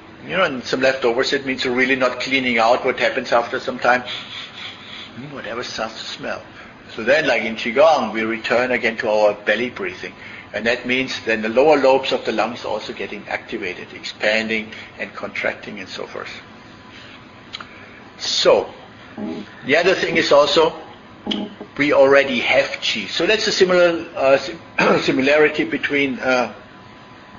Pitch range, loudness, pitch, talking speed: 115-135 Hz, -18 LUFS, 125 Hz, 155 wpm